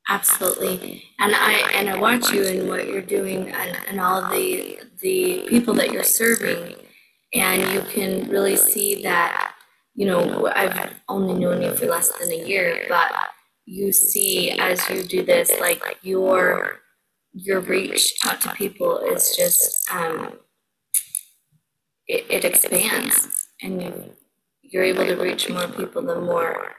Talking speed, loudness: 145 wpm, -20 LUFS